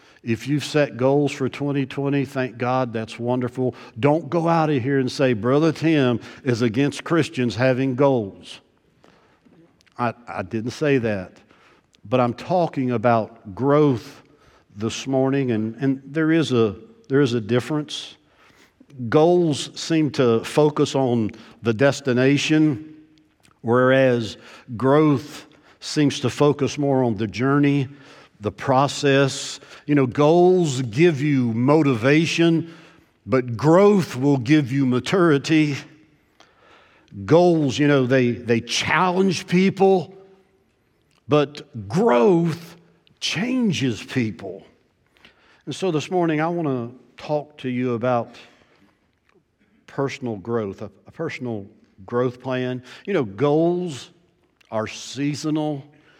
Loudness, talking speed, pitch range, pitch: -21 LUFS, 115 wpm, 120-150 Hz, 135 Hz